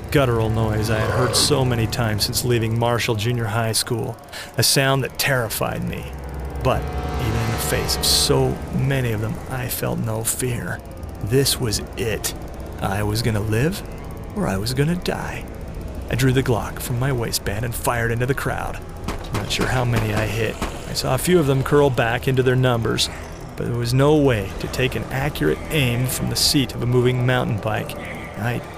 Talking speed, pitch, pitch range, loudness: 195 wpm, 115 Hz, 95-130 Hz, -21 LUFS